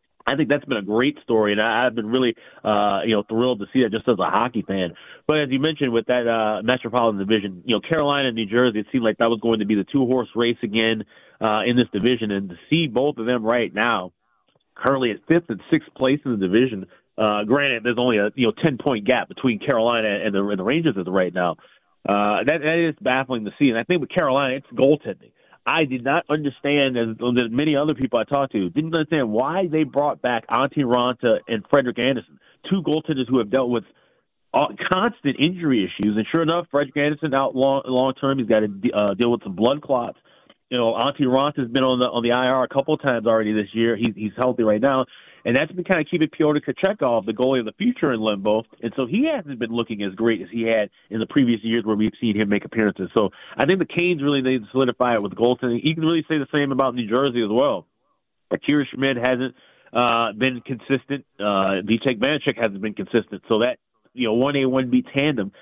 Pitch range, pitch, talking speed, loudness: 110-140 Hz, 125 Hz, 240 wpm, -21 LUFS